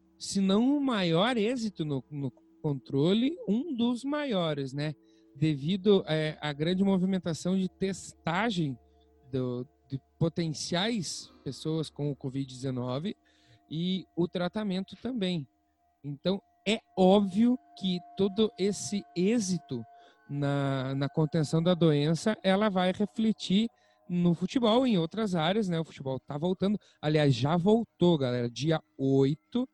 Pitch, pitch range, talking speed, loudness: 175 Hz, 145-200 Hz, 125 wpm, -29 LUFS